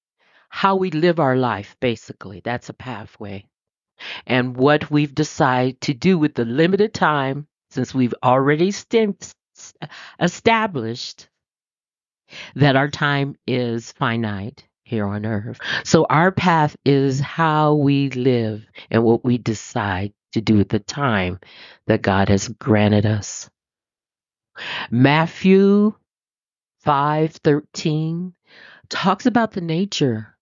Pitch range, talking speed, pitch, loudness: 115-155 Hz, 115 wpm, 135 Hz, -19 LUFS